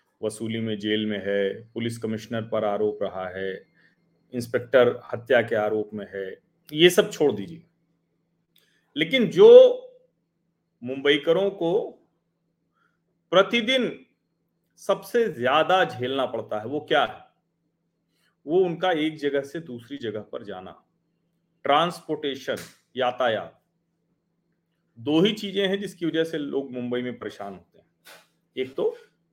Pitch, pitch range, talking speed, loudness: 155 Hz, 115-175 Hz, 125 wpm, -23 LUFS